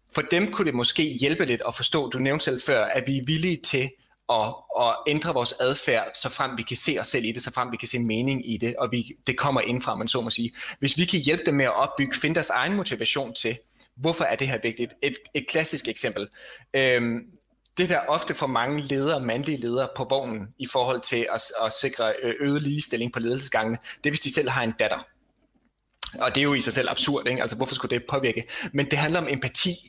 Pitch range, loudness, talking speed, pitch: 120-145 Hz, -25 LUFS, 240 wpm, 130 Hz